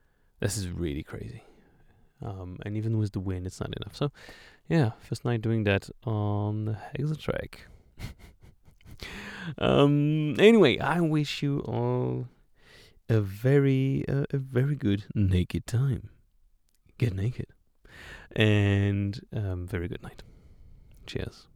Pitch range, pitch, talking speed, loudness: 100-140 Hz, 110 Hz, 125 wpm, -28 LUFS